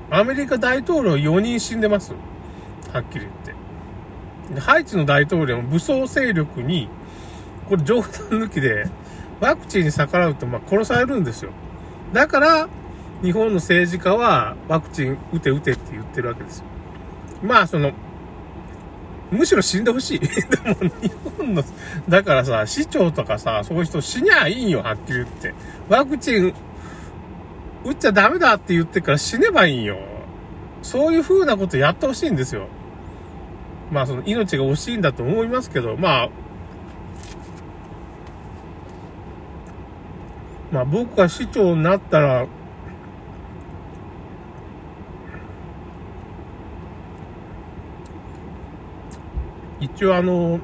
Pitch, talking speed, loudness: 130 Hz, 250 characters per minute, -19 LUFS